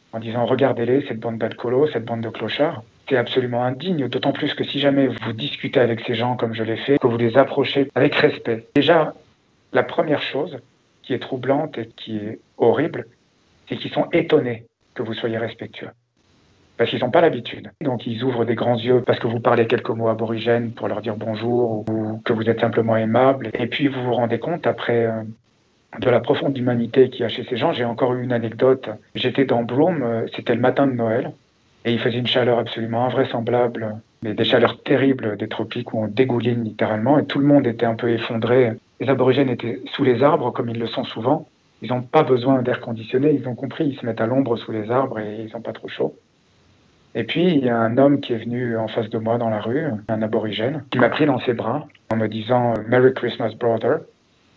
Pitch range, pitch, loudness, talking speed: 115-130 Hz, 120 Hz, -20 LUFS, 220 wpm